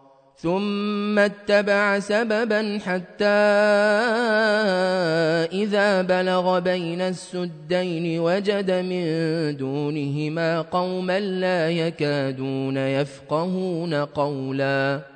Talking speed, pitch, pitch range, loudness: 65 wpm, 180 Hz, 150-205 Hz, -22 LUFS